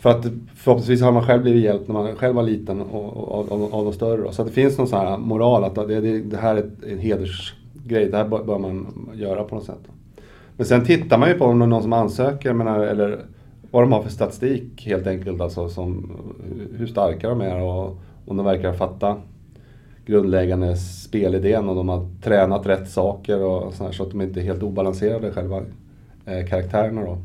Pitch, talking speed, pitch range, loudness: 105 Hz, 220 wpm, 95-115 Hz, -21 LUFS